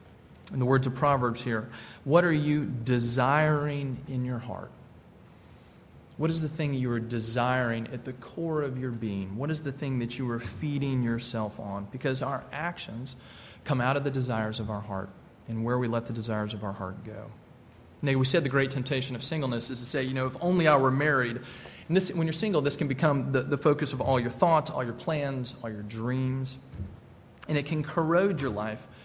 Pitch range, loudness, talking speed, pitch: 115-145 Hz, -29 LUFS, 210 wpm, 130 Hz